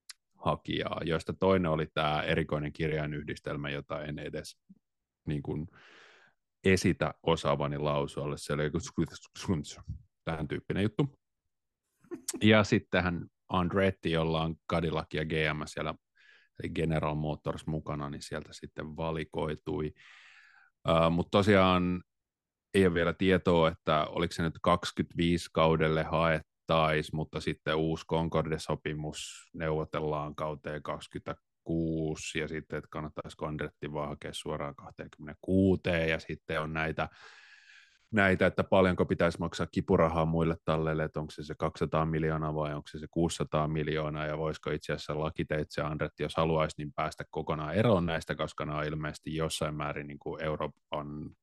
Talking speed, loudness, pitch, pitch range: 135 wpm, -31 LUFS, 80 Hz, 75-85 Hz